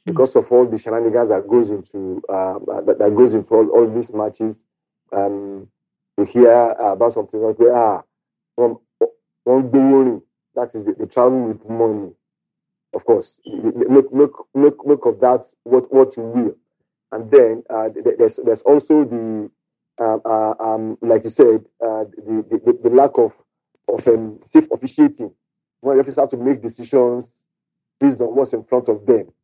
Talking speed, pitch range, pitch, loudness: 155 wpm, 110-165 Hz, 125 Hz, -16 LUFS